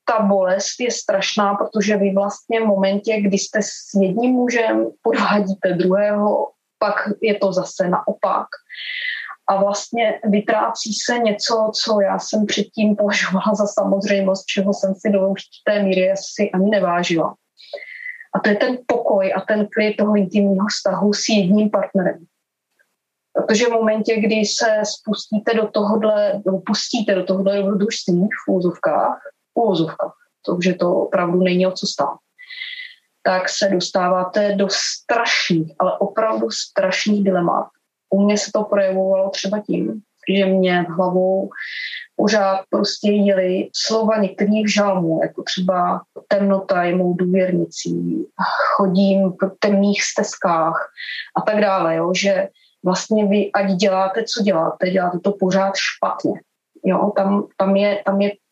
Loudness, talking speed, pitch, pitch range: -18 LUFS, 135 wpm, 200 Hz, 190-215 Hz